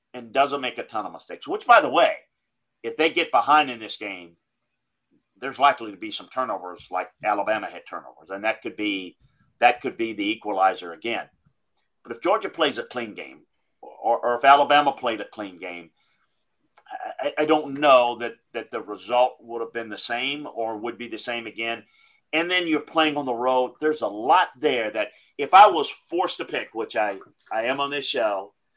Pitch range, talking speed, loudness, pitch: 115-150 Hz, 200 wpm, -23 LUFS, 125 Hz